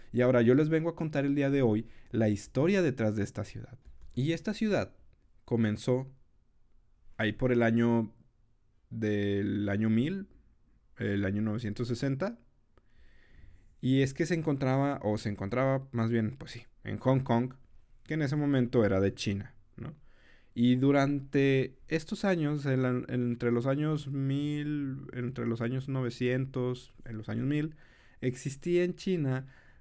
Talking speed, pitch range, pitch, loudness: 150 wpm, 115-140 Hz, 125 Hz, -30 LUFS